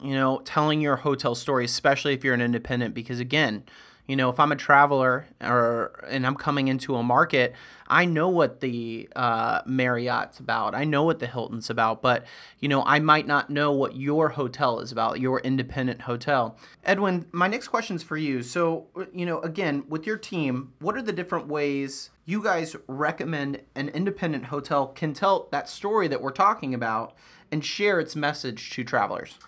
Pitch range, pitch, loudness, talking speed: 125-155 Hz, 140 Hz, -25 LUFS, 190 wpm